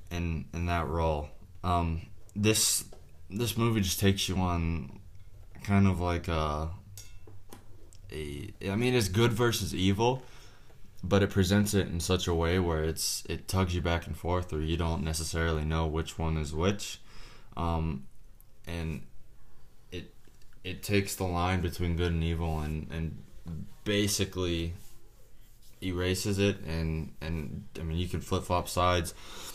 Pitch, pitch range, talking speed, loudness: 90 Hz, 80-100 Hz, 150 wpm, -30 LUFS